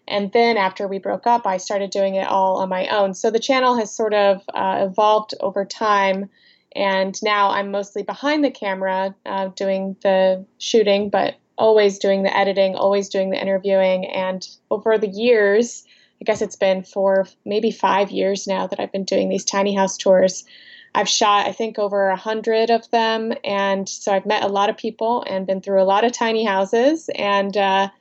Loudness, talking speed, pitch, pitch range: -19 LUFS, 195 wpm, 200 Hz, 195-220 Hz